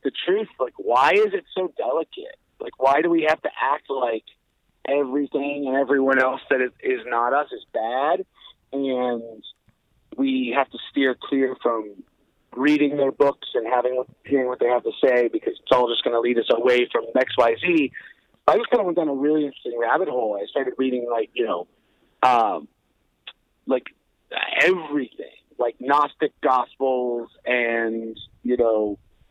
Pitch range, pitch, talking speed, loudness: 120-150 Hz, 135 Hz, 165 wpm, -22 LUFS